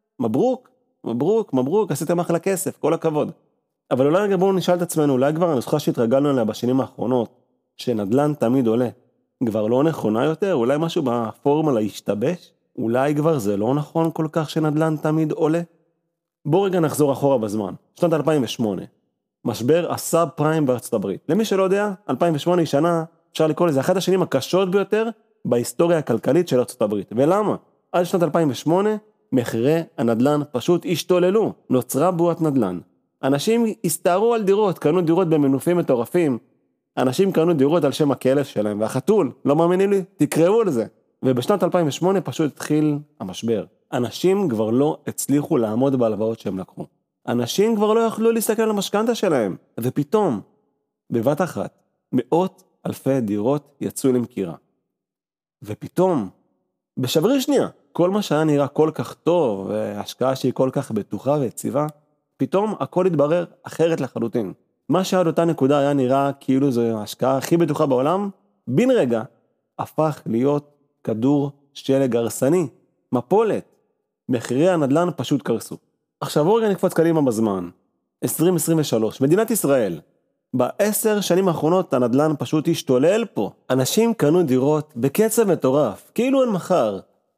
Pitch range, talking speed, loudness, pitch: 130-180 Hz, 140 wpm, -20 LUFS, 155 Hz